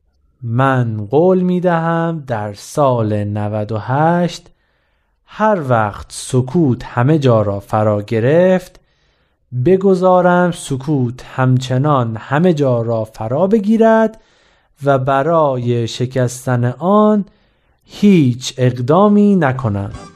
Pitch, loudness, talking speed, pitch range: 130 Hz, -15 LUFS, 90 wpm, 110-175 Hz